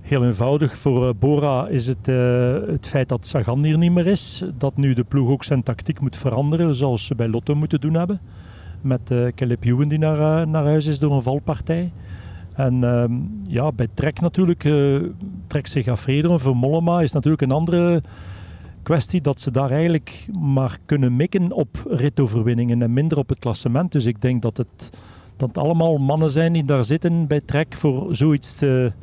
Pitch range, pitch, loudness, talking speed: 125-155 Hz, 140 Hz, -20 LUFS, 190 wpm